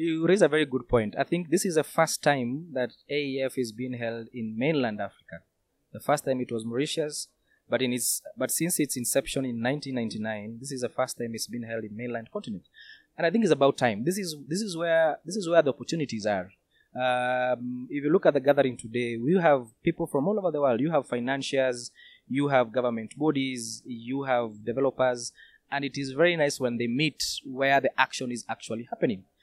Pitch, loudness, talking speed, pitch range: 130 Hz, -27 LUFS, 210 wpm, 120-150 Hz